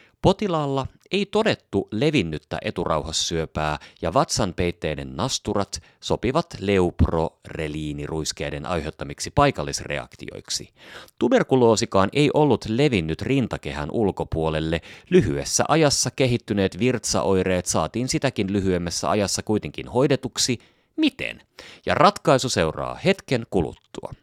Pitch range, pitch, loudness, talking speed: 80-135 Hz, 100 Hz, -23 LUFS, 85 wpm